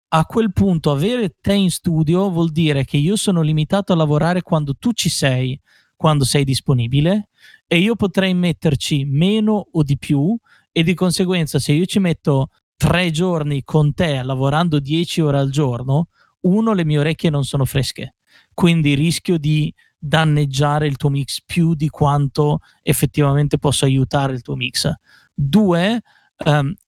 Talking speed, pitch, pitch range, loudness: 160 wpm, 155 Hz, 145-175 Hz, -17 LUFS